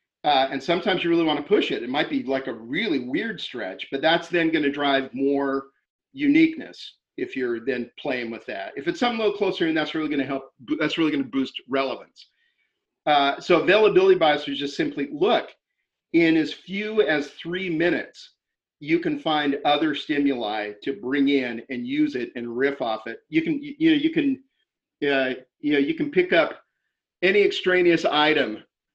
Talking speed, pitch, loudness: 195 wpm, 155 Hz, -23 LUFS